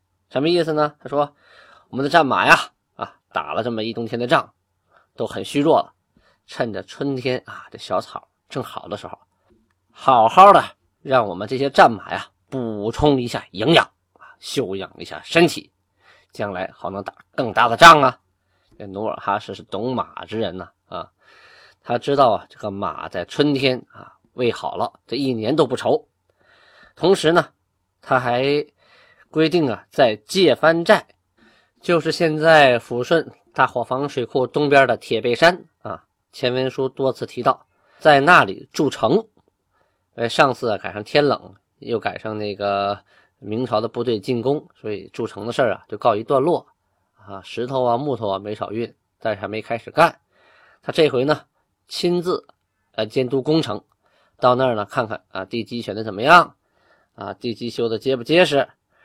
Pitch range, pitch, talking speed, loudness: 110-145 Hz, 125 Hz, 240 characters per minute, -19 LUFS